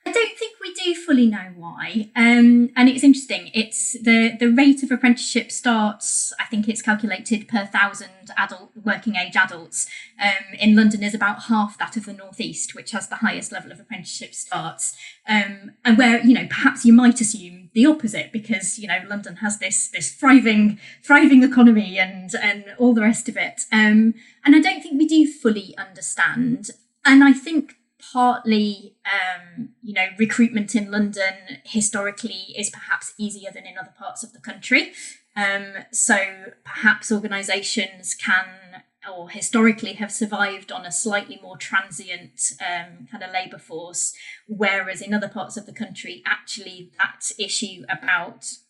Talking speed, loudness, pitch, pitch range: 165 wpm, -19 LUFS, 215 Hz, 195-240 Hz